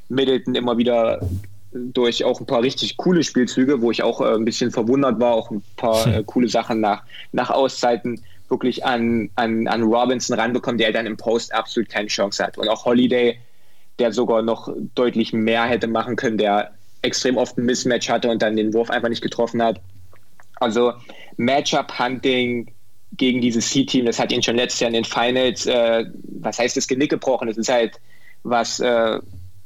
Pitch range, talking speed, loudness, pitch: 110-125 Hz, 185 wpm, -20 LUFS, 115 Hz